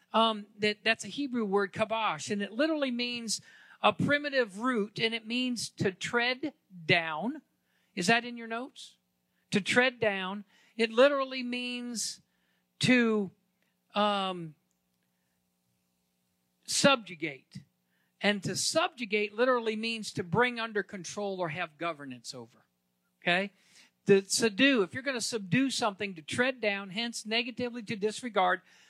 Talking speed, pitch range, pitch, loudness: 135 wpm, 175-240 Hz, 210 Hz, -30 LUFS